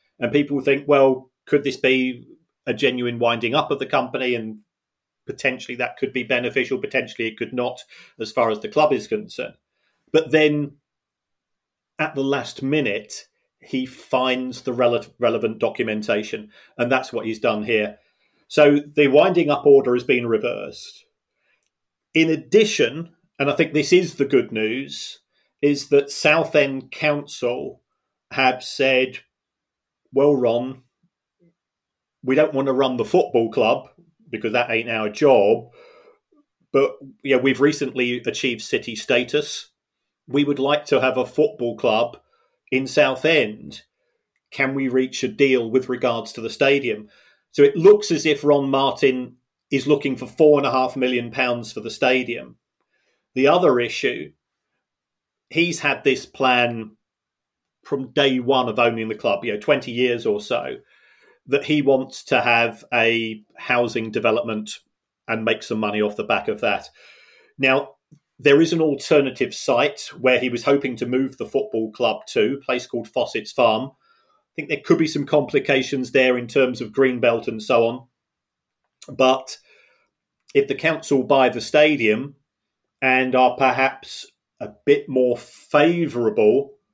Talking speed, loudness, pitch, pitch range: 150 wpm, -20 LUFS, 130 Hz, 120-145 Hz